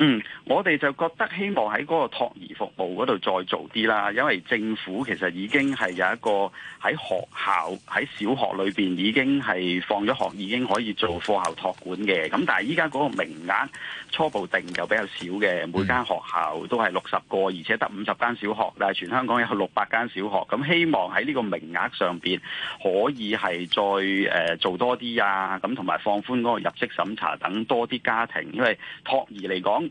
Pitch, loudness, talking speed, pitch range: 105 Hz, -25 LUFS, 290 characters per minute, 95-120 Hz